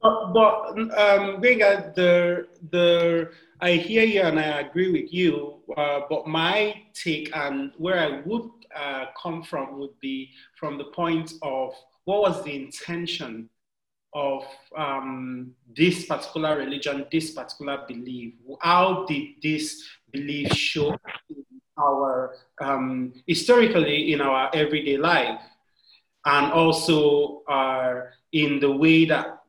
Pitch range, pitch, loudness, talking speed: 140-175 Hz, 155 Hz, -23 LUFS, 130 wpm